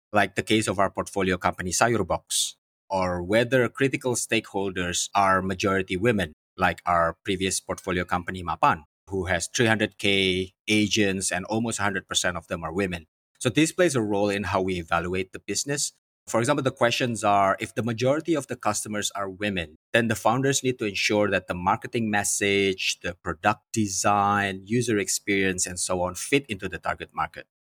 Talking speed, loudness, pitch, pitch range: 170 wpm, -25 LUFS, 100 Hz, 95-115 Hz